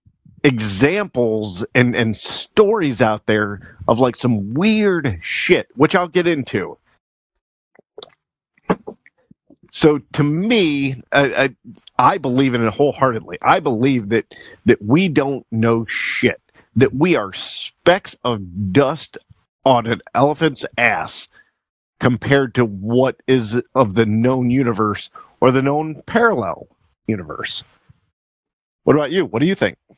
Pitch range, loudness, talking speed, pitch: 115-145 Hz, -18 LUFS, 125 wpm, 130 Hz